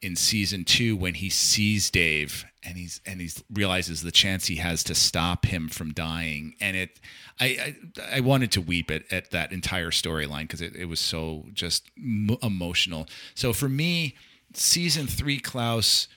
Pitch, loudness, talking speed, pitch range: 90 Hz, -25 LUFS, 175 wpm, 85-110 Hz